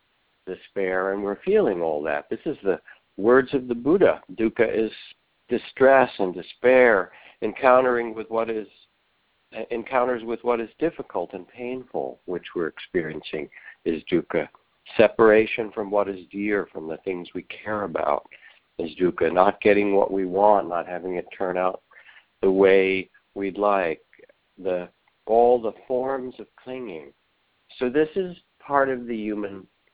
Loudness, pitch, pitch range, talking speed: -23 LUFS, 110 Hz, 95-125 Hz, 150 wpm